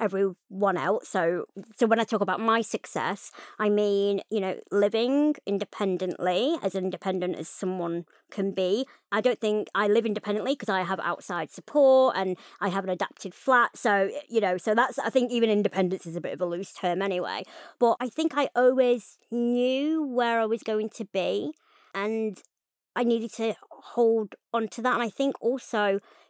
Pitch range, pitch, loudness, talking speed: 195-240 Hz, 215 Hz, -27 LUFS, 185 wpm